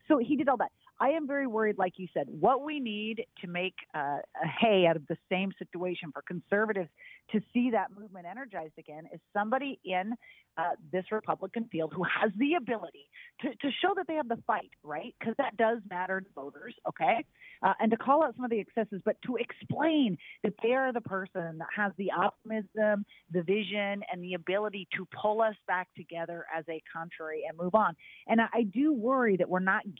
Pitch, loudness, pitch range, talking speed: 205 Hz, -31 LUFS, 180-235 Hz, 210 wpm